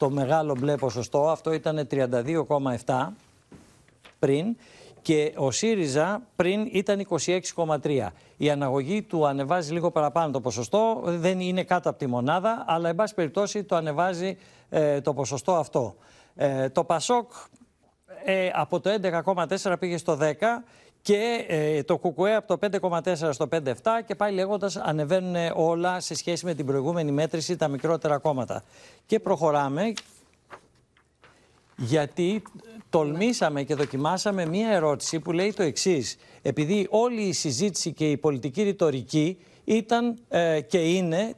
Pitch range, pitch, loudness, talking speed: 150-195 Hz, 170 Hz, -26 LUFS, 135 wpm